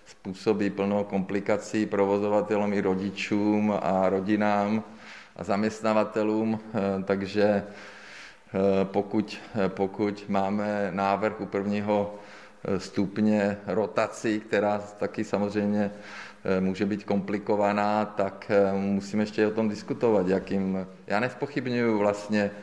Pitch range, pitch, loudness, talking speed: 100-105 Hz, 105 Hz, -27 LUFS, 95 wpm